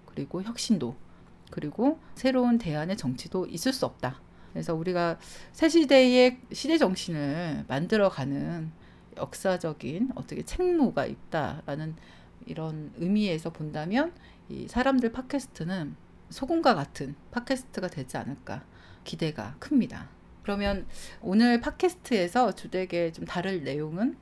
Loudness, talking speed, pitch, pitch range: -28 LUFS, 285 characters per minute, 190 Hz, 155-250 Hz